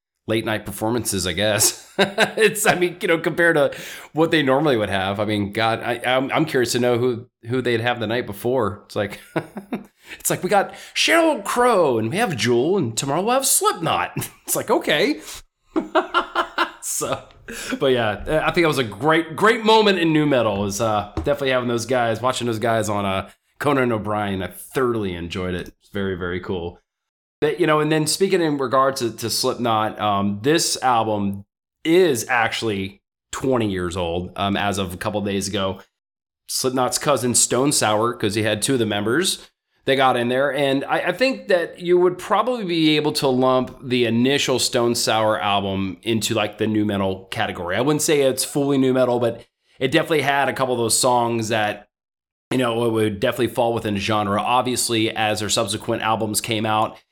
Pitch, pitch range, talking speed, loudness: 120 Hz, 105-140 Hz, 195 wpm, -20 LUFS